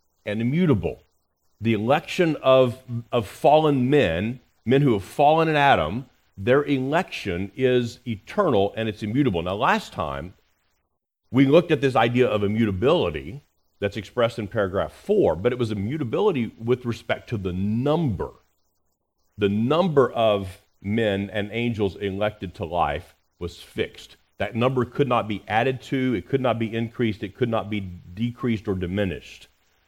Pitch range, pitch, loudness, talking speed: 95-125 Hz, 110 Hz, -23 LUFS, 150 wpm